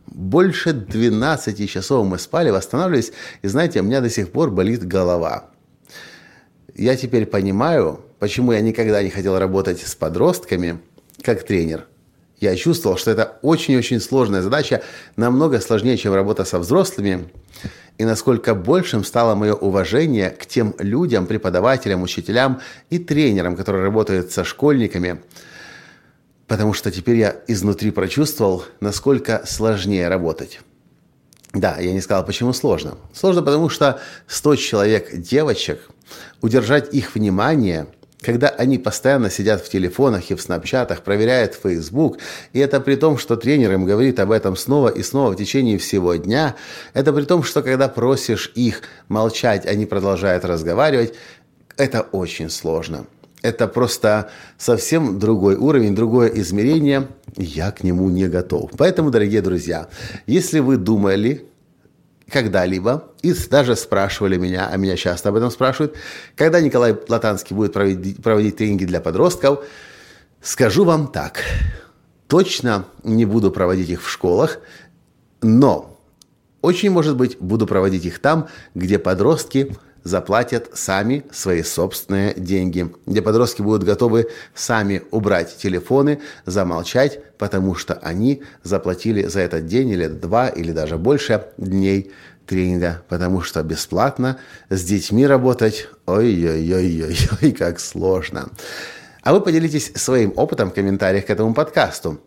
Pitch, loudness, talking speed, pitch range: 110 Hz, -18 LUFS, 135 wpm, 95-130 Hz